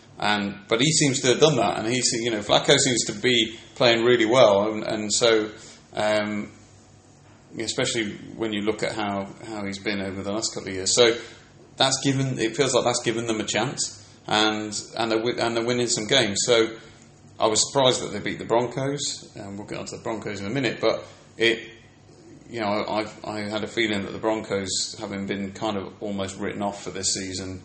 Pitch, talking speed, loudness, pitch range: 110 Hz, 220 wpm, -23 LUFS, 105-120 Hz